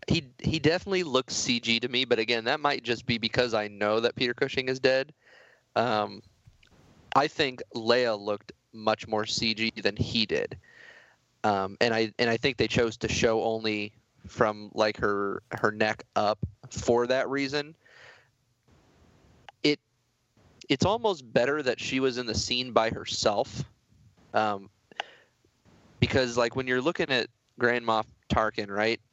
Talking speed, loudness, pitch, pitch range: 150 wpm, -28 LUFS, 115 Hz, 110-125 Hz